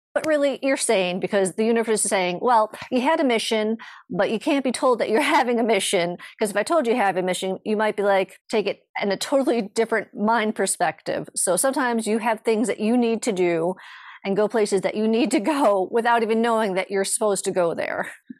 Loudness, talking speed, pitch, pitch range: -22 LUFS, 235 wpm, 220 Hz, 195-245 Hz